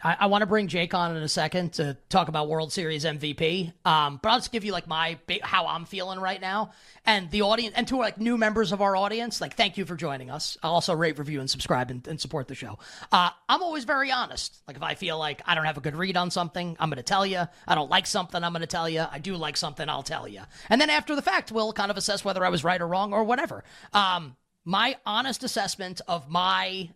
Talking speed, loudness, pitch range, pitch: 260 wpm, -26 LUFS, 160-205 Hz, 180 Hz